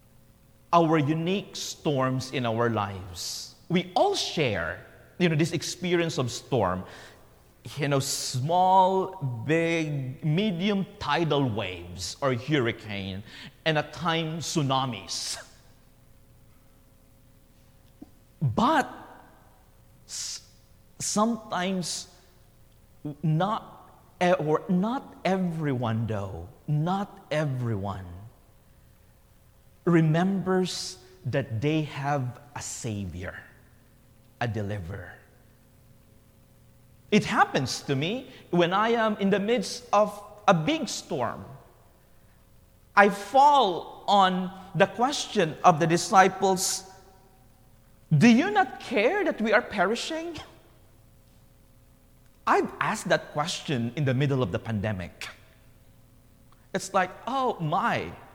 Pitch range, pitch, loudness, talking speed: 120-190 Hz, 155 Hz, -26 LUFS, 90 wpm